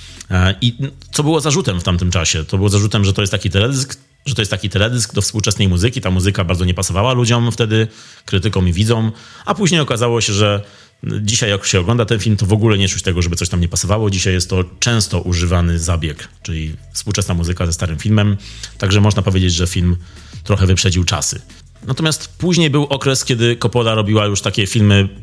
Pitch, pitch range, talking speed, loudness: 105 Hz, 95-115 Hz, 200 wpm, -16 LUFS